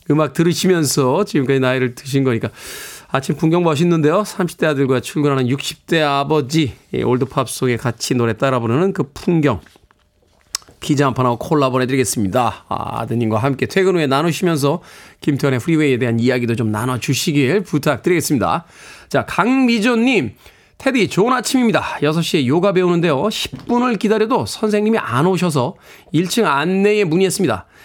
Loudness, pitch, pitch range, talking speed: -17 LUFS, 150 Hz, 130-185 Hz, 355 characters per minute